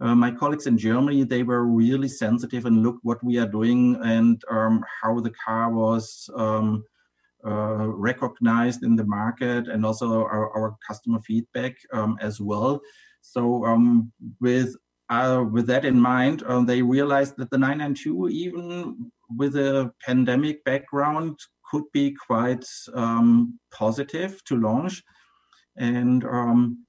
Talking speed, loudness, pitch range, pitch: 145 wpm, -23 LUFS, 115-135 Hz, 120 Hz